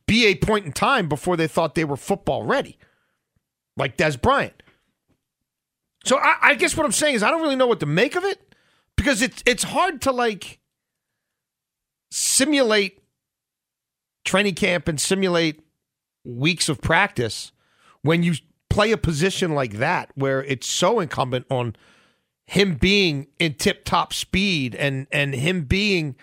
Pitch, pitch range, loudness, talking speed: 175 Hz, 140-210 Hz, -21 LUFS, 155 wpm